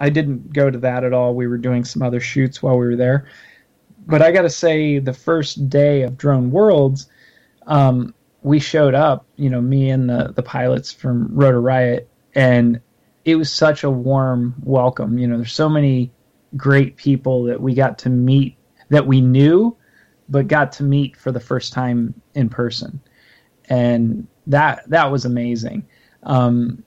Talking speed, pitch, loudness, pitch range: 180 wpm, 130 Hz, -17 LUFS, 125-145 Hz